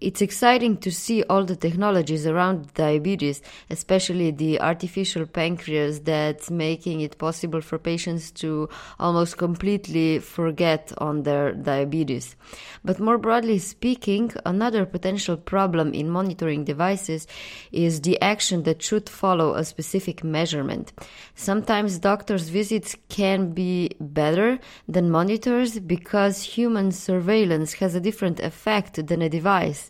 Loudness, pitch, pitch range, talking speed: -23 LUFS, 175 Hz, 160-200 Hz, 125 wpm